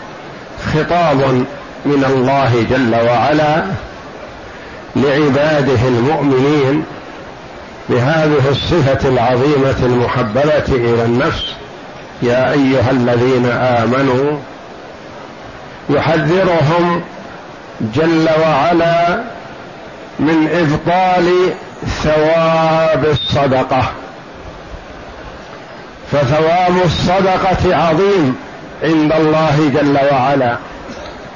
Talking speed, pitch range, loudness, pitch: 60 wpm, 130-160 Hz, -13 LUFS, 145 Hz